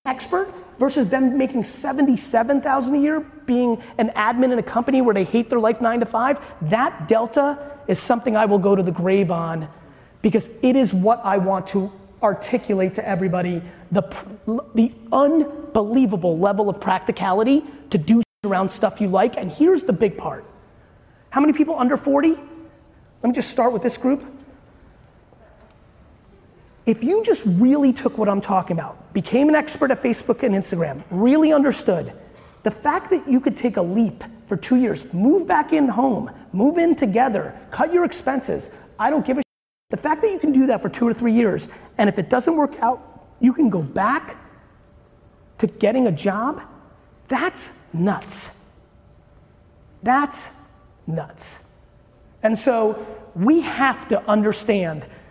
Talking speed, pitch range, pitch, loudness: 160 wpm, 205-275 Hz, 235 Hz, -20 LUFS